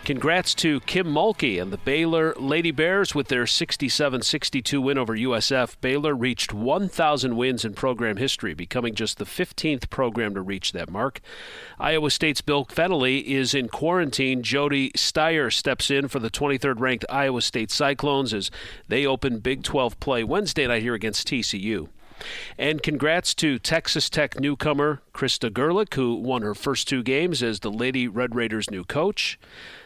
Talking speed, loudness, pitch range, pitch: 160 wpm, -23 LUFS, 120-150 Hz, 135 Hz